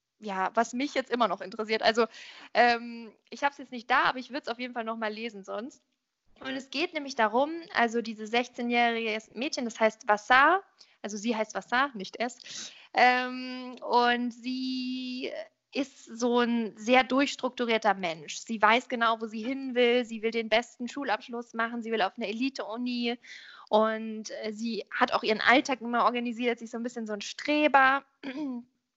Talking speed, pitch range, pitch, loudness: 180 wpm, 225-260 Hz, 240 Hz, -28 LUFS